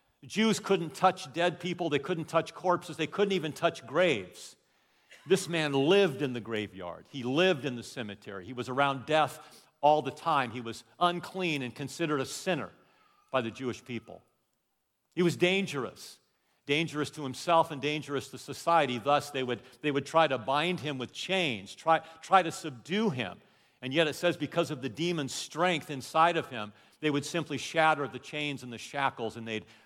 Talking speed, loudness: 185 wpm, -30 LUFS